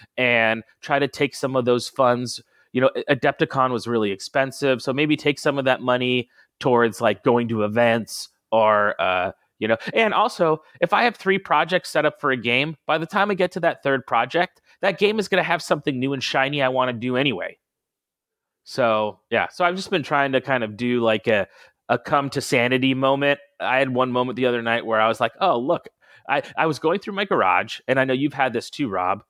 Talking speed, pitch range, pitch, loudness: 230 wpm, 120-150 Hz, 130 Hz, -21 LUFS